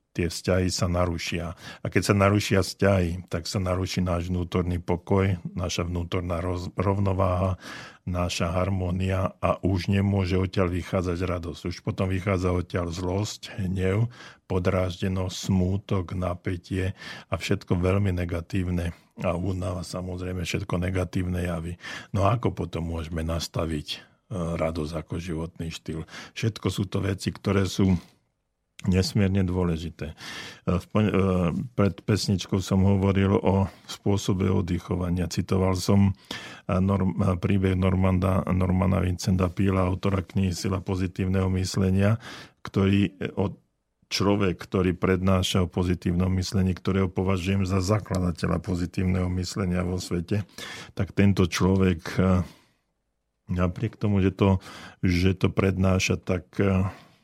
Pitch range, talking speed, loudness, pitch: 90-100 Hz, 115 wpm, -26 LUFS, 95 Hz